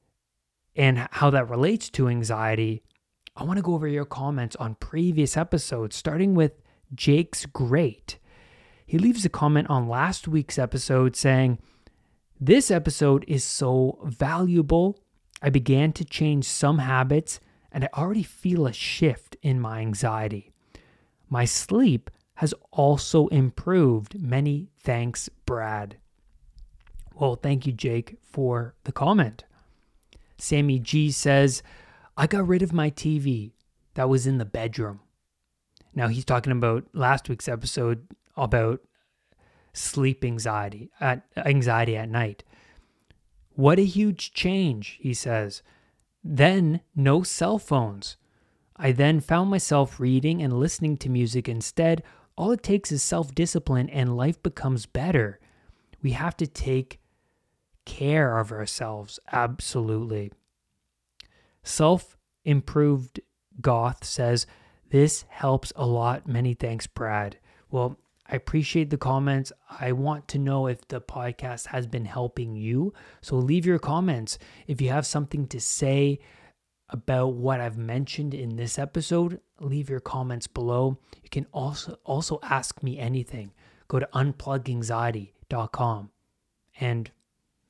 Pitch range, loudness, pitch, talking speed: 115-150 Hz, -25 LUFS, 130 Hz, 125 wpm